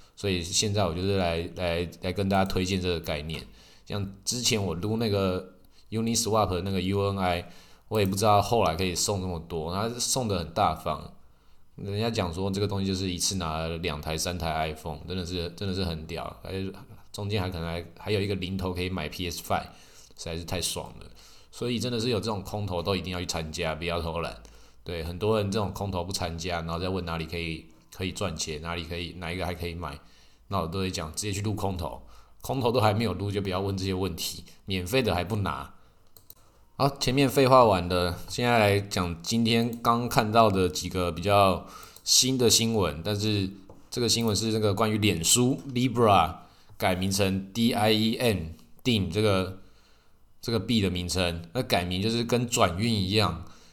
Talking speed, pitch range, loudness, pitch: 305 characters per minute, 85-110 Hz, -27 LUFS, 95 Hz